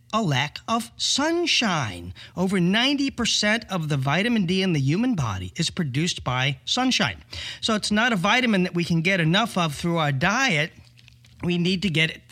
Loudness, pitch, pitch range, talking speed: -22 LUFS, 175 Hz, 145-220 Hz, 180 wpm